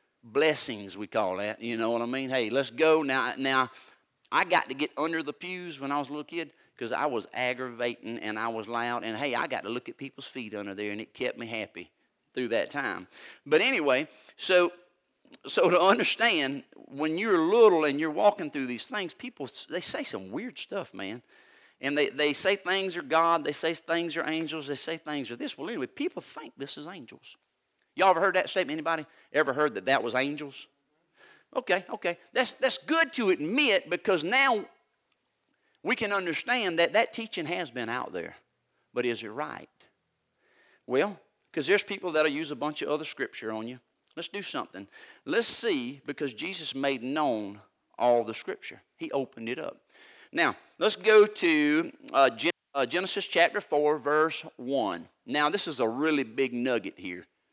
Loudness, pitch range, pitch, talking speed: -28 LUFS, 130-185 Hz, 155 Hz, 190 wpm